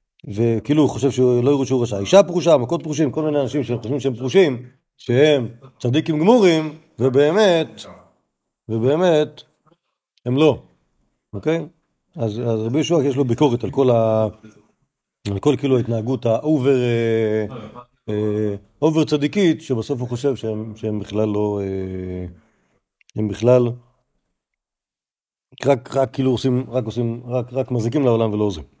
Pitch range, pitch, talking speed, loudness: 110-145 Hz, 125 Hz, 140 wpm, -19 LUFS